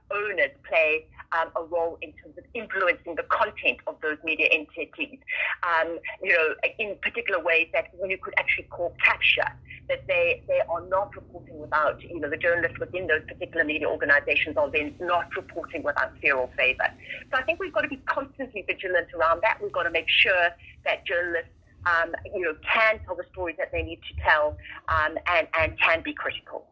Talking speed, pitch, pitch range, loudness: 200 wpm, 180 Hz, 165-270 Hz, -25 LUFS